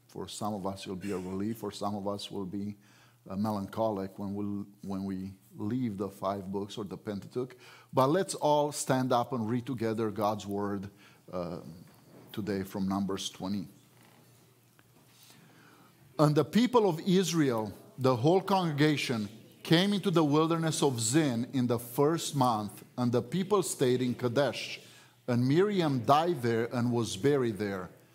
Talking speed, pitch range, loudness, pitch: 160 wpm, 100-145 Hz, -31 LUFS, 120 Hz